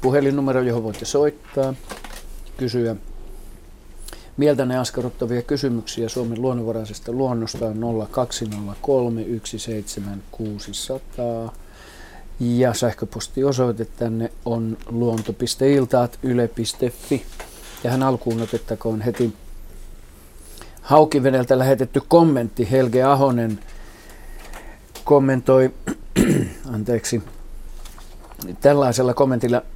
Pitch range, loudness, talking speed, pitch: 110-130 Hz, -21 LUFS, 65 wpm, 120 Hz